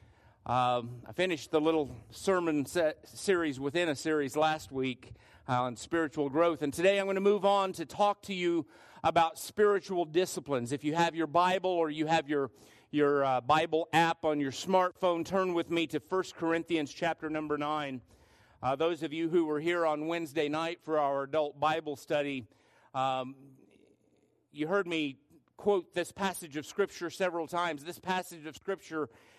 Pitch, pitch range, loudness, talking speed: 160 Hz, 140-175 Hz, -31 LUFS, 180 wpm